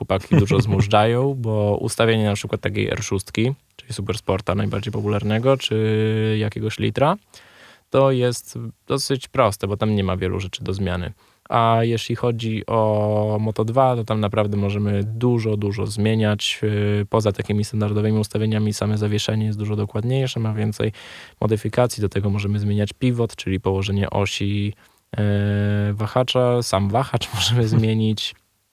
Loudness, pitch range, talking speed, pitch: -21 LUFS, 105-115 Hz, 135 wpm, 105 Hz